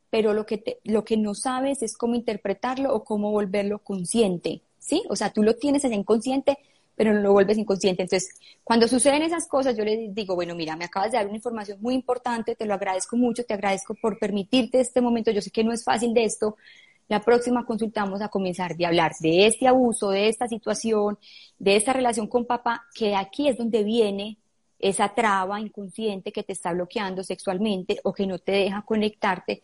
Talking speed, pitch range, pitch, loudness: 205 wpm, 200-235 Hz, 215 Hz, -24 LUFS